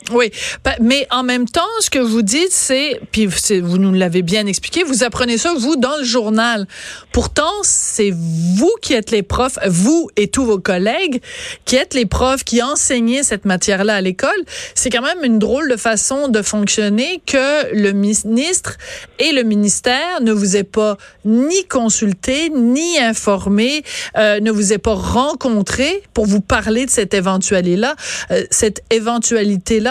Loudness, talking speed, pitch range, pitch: -15 LUFS, 170 wpm, 210-265 Hz, 235 Hz